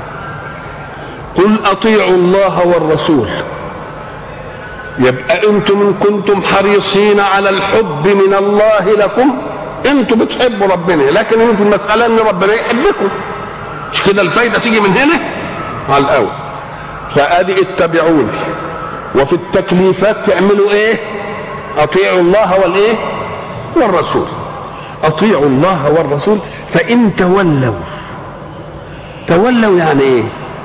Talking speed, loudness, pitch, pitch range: 95 wpm, -11 LUFS, 195 Hz, 170-210 Hz